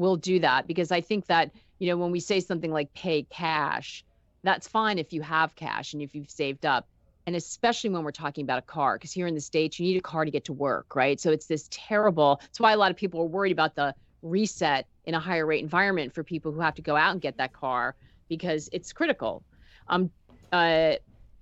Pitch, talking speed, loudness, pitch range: 165 Hz, 240 wpm, -27 LUFS, 155-180 Hz